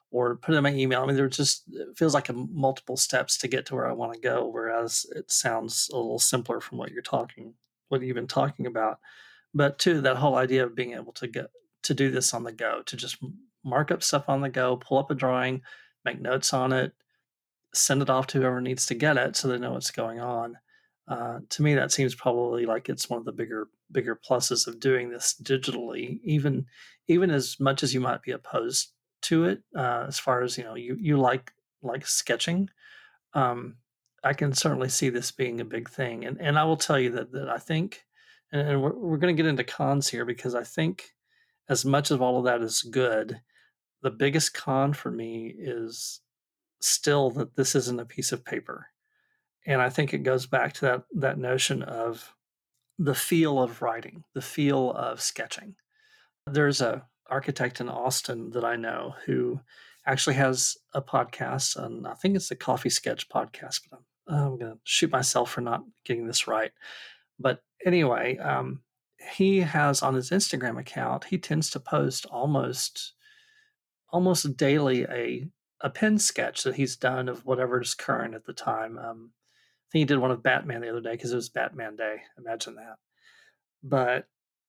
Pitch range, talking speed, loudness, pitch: 125-150 Hz, 200 wpm, -27 LUFS, 130 Hz